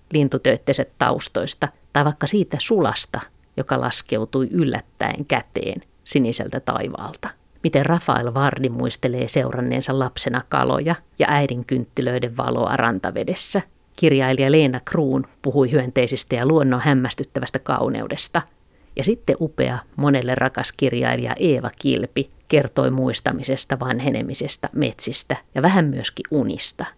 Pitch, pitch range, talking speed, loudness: 135 Hz, 125-145 Hz, 110 wpm, -21 LUFS